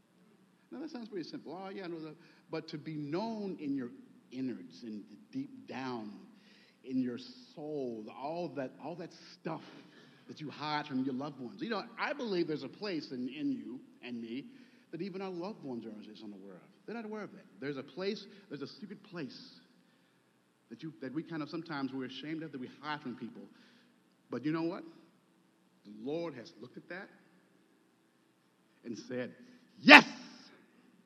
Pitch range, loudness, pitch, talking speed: 130-205 Hz, -34 LUFS, 160 Hz, 185 wpm